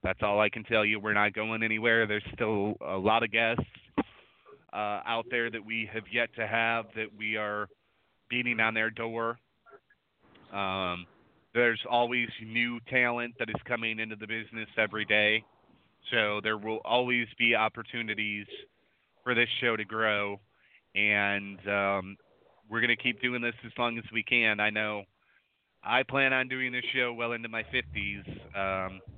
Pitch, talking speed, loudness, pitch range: 110 Hz, 165 wpm, -29 LUFS, 105-120 Hz